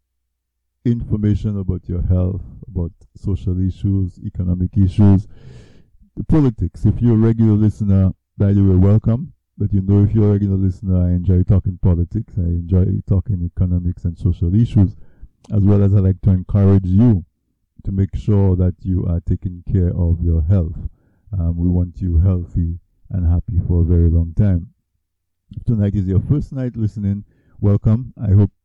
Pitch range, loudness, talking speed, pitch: 90-105 Hz, -18 LUFS, 170 wpm, 95 Hz